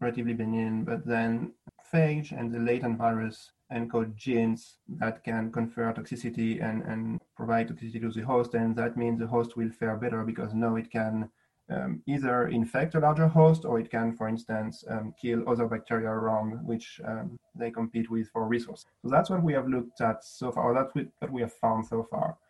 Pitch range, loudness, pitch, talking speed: 115-120 Hz, -30 LUFS, 115 Hz, 195 wpm